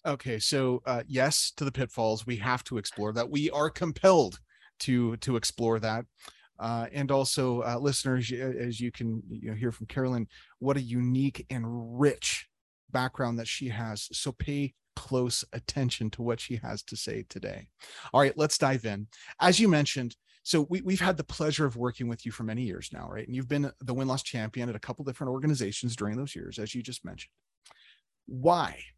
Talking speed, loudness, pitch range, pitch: 195 wpm, -30 LUFS, 115-140 Hz, 125 Hz